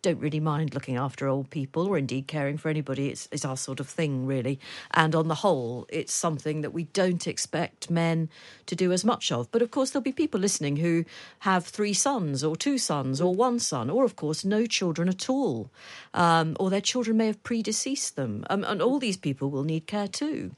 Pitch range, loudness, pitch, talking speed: 150-210 Hz, -27 LUFS, 170 Hz, 220 wpm